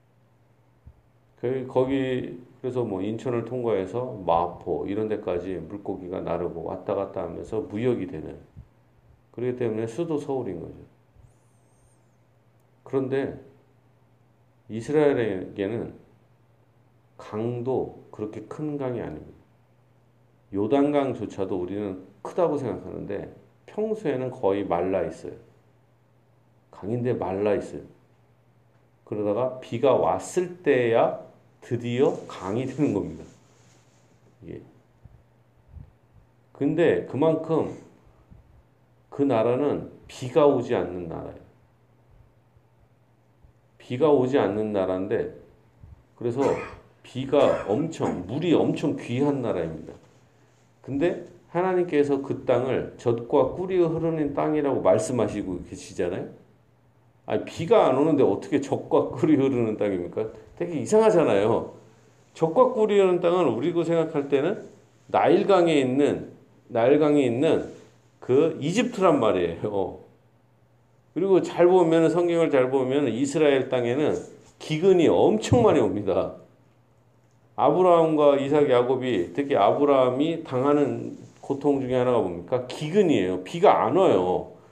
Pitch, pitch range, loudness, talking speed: 125 Hz, 115-145 Hz, -24 LUFS, 245 characters per minute